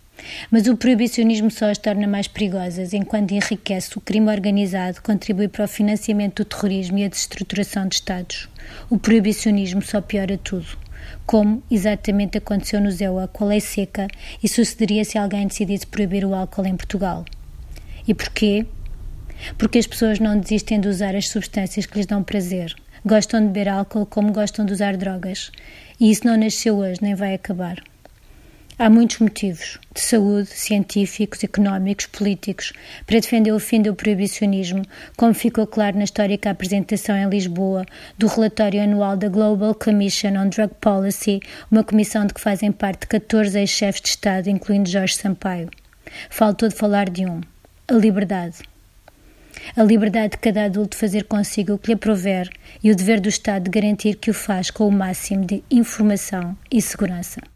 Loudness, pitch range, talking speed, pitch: -20 LUFS, 195-215 Hz, 165 wpm, 205 Hz